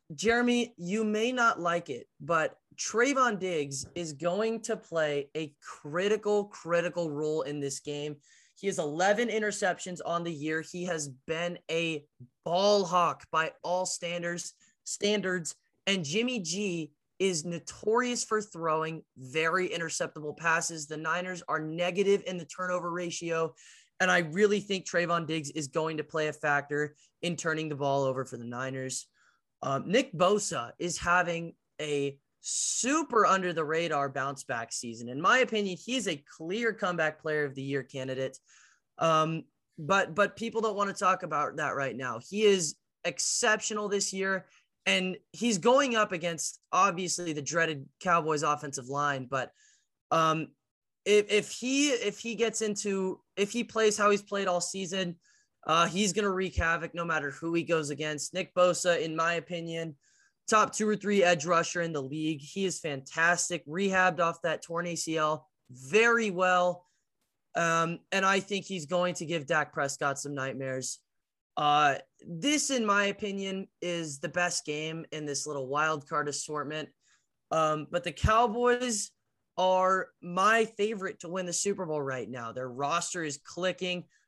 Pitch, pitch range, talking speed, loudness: 175 Hz, 155-195 Hz, 160 wpm, -30 LUFS